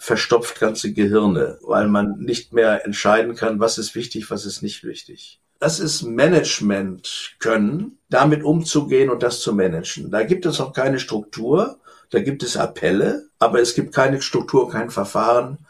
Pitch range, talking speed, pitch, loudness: 105-145 Hz, 165 wpm, 120 Hz, -19 LUFS